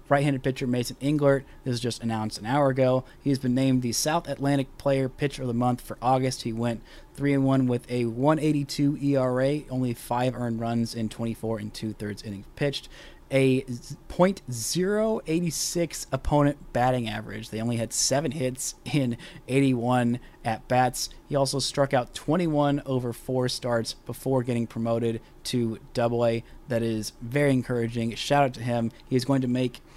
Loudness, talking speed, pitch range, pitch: -26 LUFS, 165 wpm, 120-140 Hz, 125 Hz